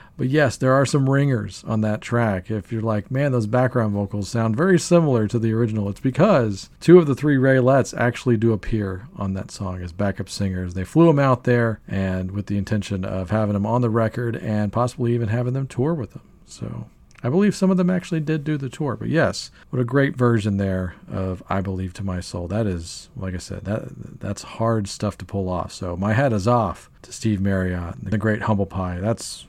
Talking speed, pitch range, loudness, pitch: 225 wpm, 100-130 Hz, -22 LUFS, 110 Hz